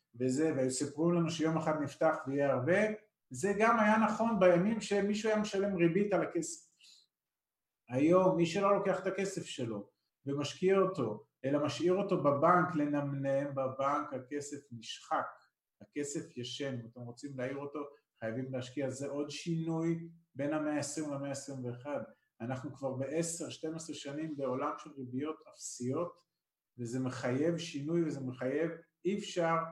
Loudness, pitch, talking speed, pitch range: -34 LUFS, 150 Hz, 140 wpm, 135-175 Hz